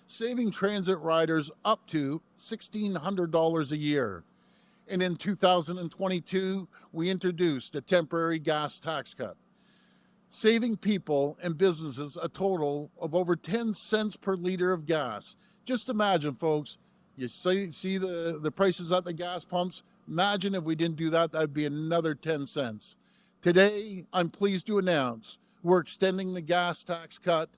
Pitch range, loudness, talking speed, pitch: 165-200 Hz, -29 LUFS, 145 wpm, 180 Hz